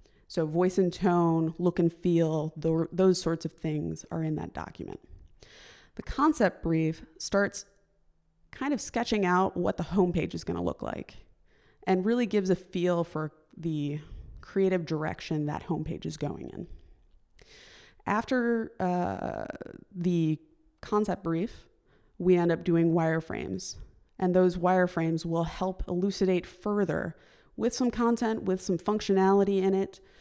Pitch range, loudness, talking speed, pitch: 165-200 Hz, -29 LUFS, 140 wpm, 180 Hz